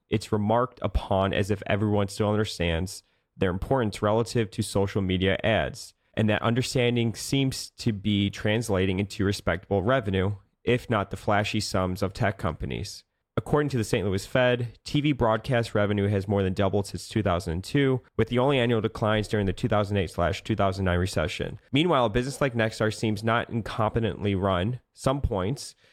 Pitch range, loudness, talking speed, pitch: 100-115 Hz, -26 LUFS, 160 wpm, 105 Hz